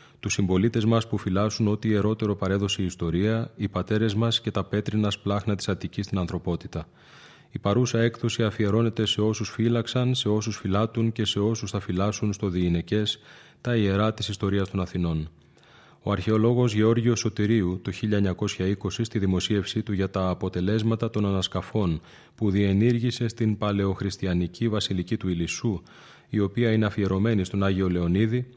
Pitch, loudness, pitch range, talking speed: 105 Hz, -25 LUFS, 95-110 Hz, 150 wpm